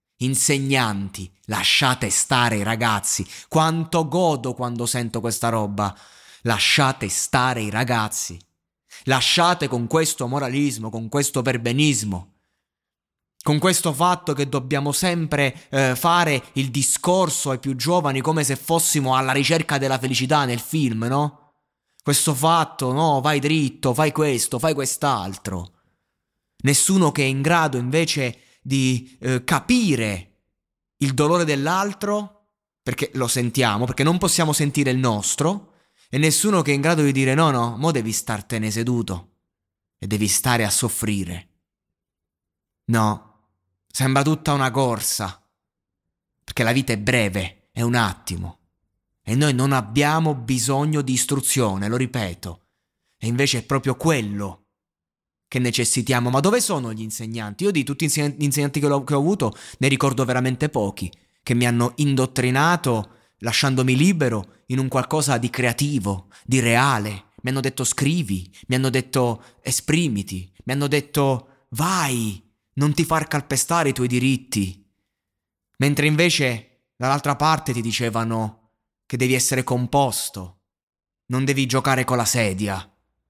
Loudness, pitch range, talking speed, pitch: -21 LUFS, 110-145 Hz, 140 wpm, 130 Hz